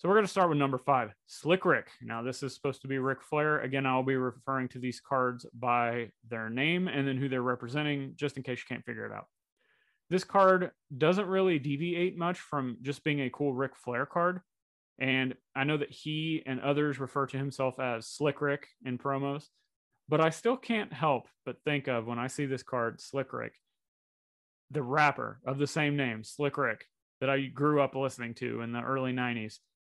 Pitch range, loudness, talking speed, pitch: 130-150 Hz, -31 LUFS, 205 wpm, 135 Hz